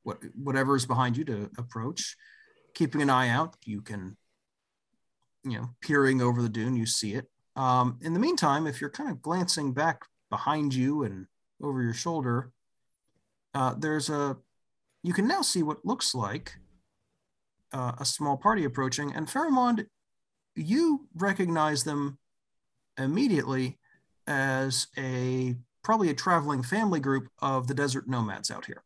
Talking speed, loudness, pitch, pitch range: 150 wpm, -29 LUFS, 140 Hz, 125-165 Hz